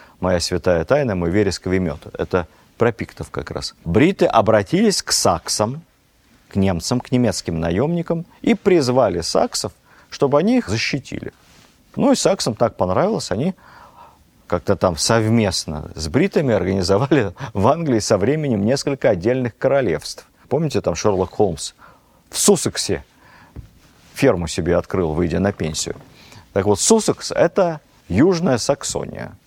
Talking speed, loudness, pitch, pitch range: 130 wpm, -19 LUFS, 105 Hz, 90-140 Hz